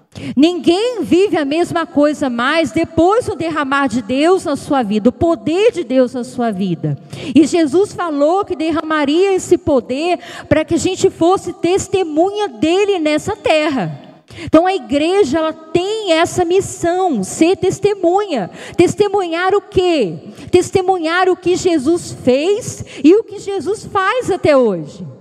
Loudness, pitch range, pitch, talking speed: -15 LUFS, 300-375 Hz, 335 Hz, 145 wpm